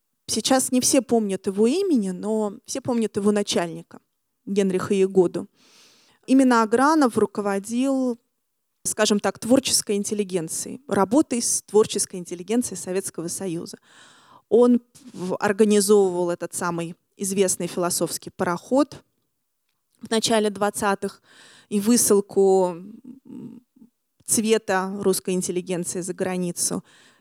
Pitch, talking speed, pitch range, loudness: 205 Hz, 95 wpm, 185-235 Hz, -22 LUFS